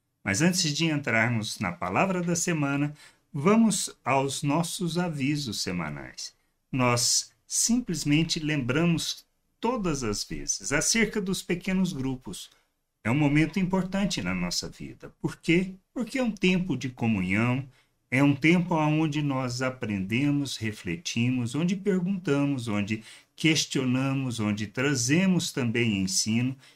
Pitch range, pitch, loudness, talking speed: 120-175 Hz, 145 Hz, -26 LUFS, 120 wpm